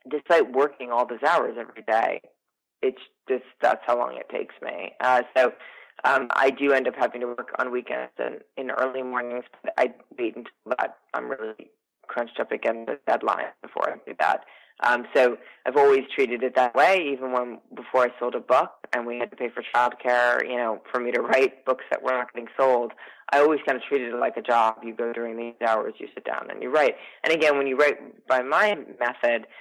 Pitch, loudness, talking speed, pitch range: 125 Hz, -25 LUFS, 220 wpm, 120-135 Hz